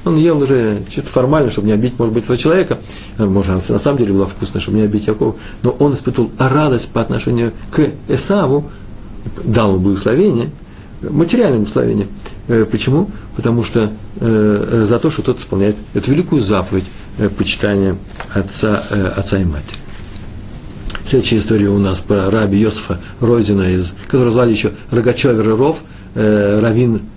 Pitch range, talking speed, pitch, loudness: 100-125 Hz, 145 wpm, 110 Hz, -15 LUFS